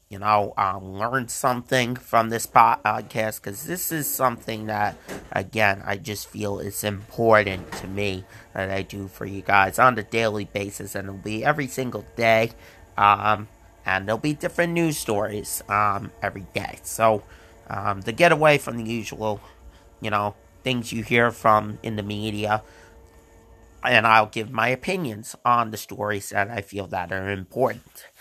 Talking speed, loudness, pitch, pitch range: 165 wpm, -23 LUFS, 105 Hz, 100-115 Hz